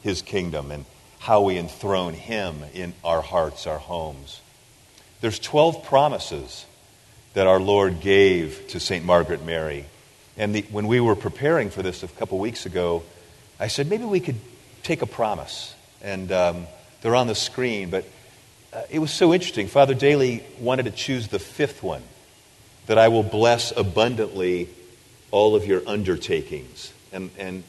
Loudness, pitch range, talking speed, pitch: -22 LUFS, 95-125 Hz, 165 wpm, 105 Hz